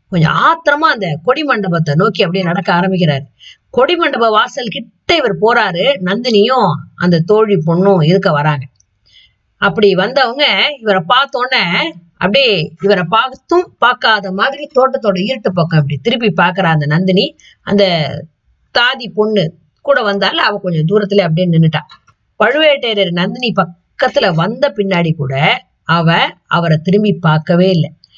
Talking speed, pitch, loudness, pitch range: 125 wpm, 190 Hz, -12 LUFS, 165-225 Hz